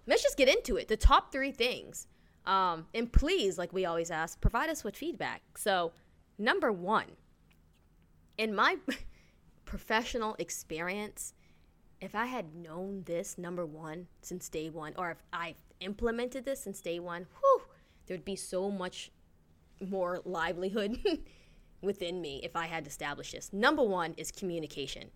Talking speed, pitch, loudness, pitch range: 150 wpm, 180 Hz, -33 LUFS, 160-220 Hz